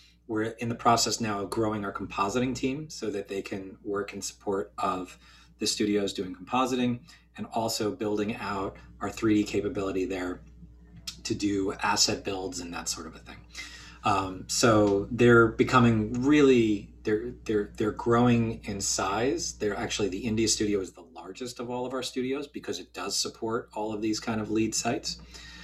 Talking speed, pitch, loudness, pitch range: 175 wpm, 110 Hz, -28 LUFS, 100-120 Hz